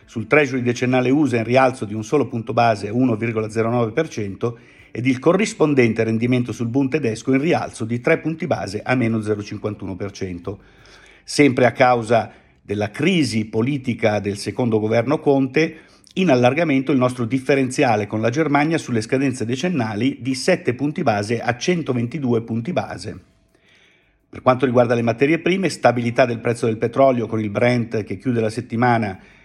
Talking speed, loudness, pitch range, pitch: 155 wpm, -19 LUFS, 110-135 Hz, 120 Hz